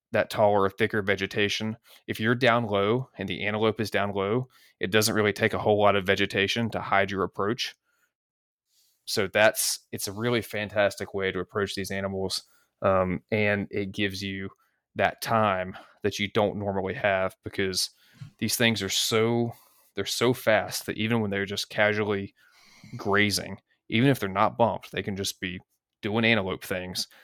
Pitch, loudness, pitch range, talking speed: 100 Hz, -26 LUFS, 100-110 Hz, 170 wpm